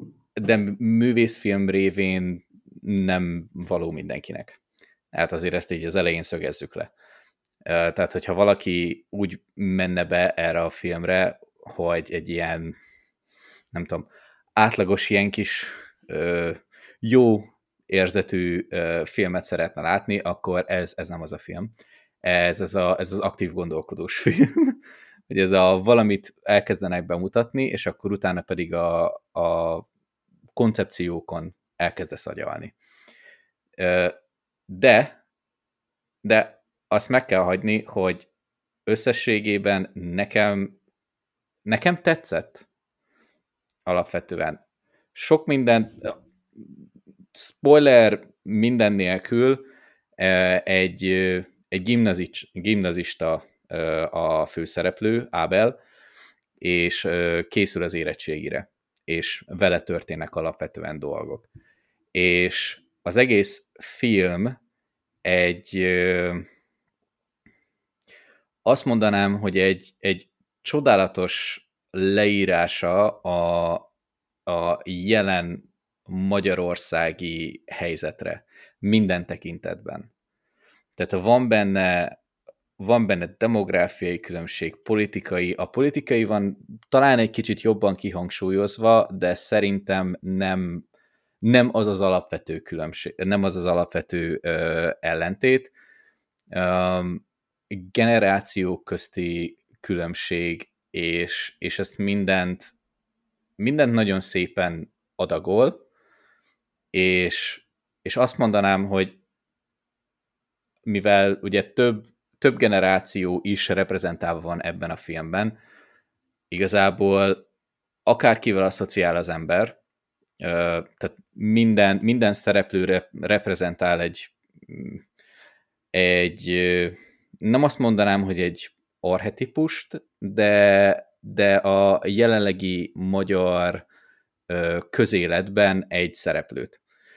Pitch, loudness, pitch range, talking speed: 95 Hz, -22 LUFS, 90-105 Hz, 90 wpm